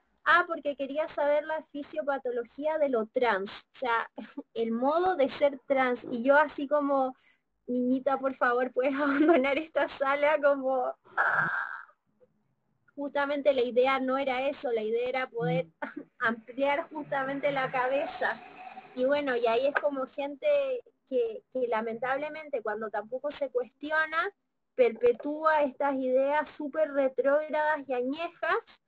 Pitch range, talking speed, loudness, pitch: 255-305 Hz, 135 wpm, -29 LUFS, 280 Hz